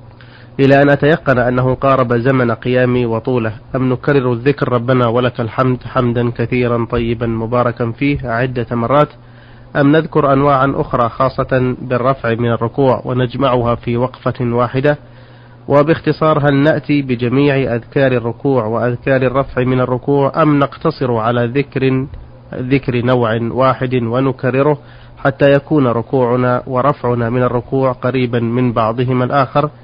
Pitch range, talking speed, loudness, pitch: 120-140 Hz, 125 wpm, -14 LUFS, 125 Hz